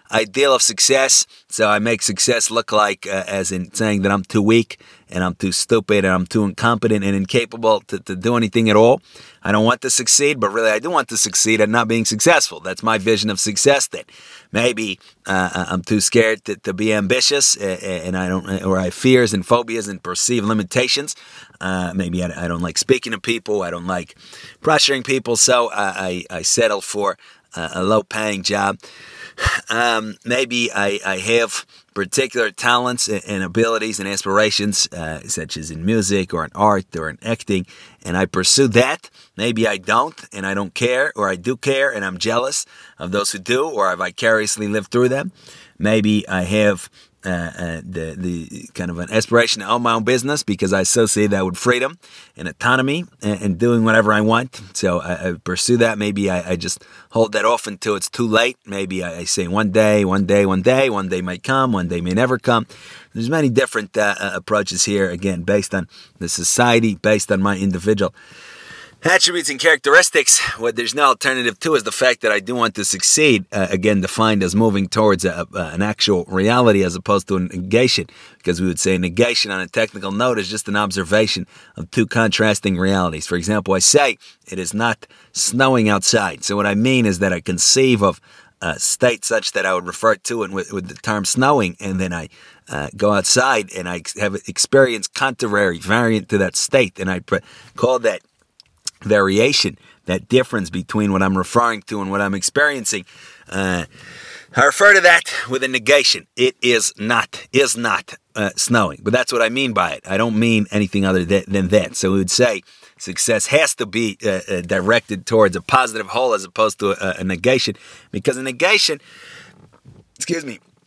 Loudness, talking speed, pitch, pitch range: -17 LUFS, 200 wpm, 105 Hz, 95-115 Hz